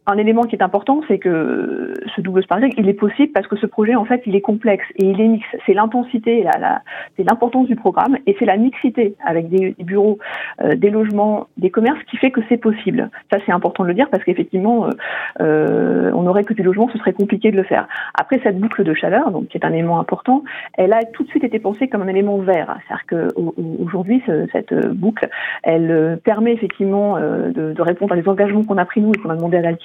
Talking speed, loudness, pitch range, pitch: 245 wpm, -17 LUFS, 190-240 Hz, 210 Hz